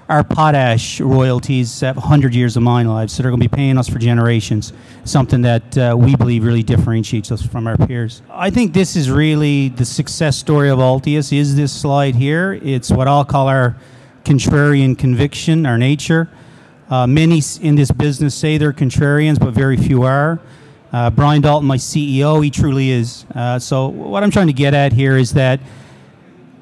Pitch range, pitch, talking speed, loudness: 125-150 Hz, 135 Hz, 185 wpm, -14 LUFS